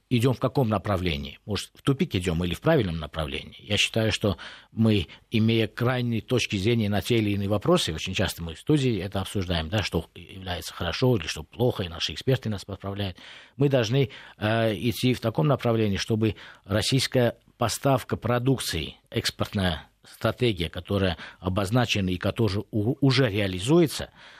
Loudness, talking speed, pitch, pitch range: -26 LUFS, 155 wpm, 110 Hz, 95-120 Hz